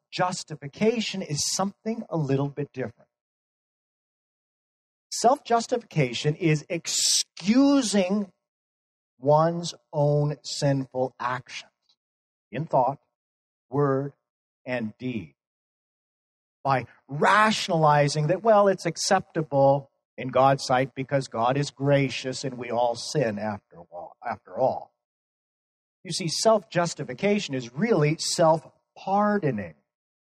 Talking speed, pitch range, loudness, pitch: 95 wpm, 130-185 Hz, -25 LUFS, 145 Hz